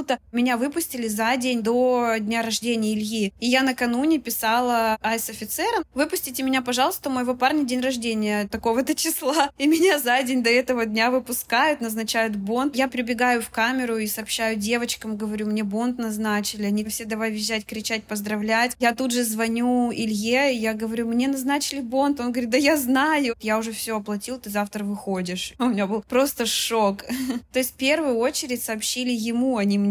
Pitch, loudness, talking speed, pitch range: 240 Hz, -23 LUFS, 175 wpm, 220-260 Hz